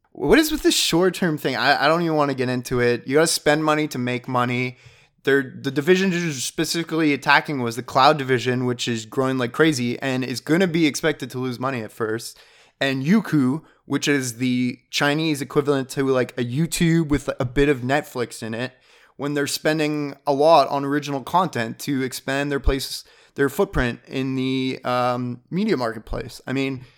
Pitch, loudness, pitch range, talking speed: 140 Hz, -21 LUFS, 125-150 Hz, 200 wpm